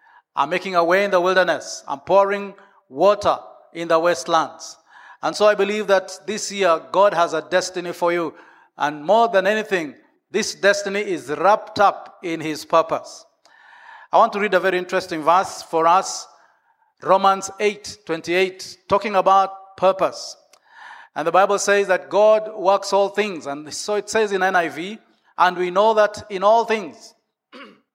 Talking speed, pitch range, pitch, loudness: 165 wpm, 175-210 Hz, 195 Hz, -19 LUFS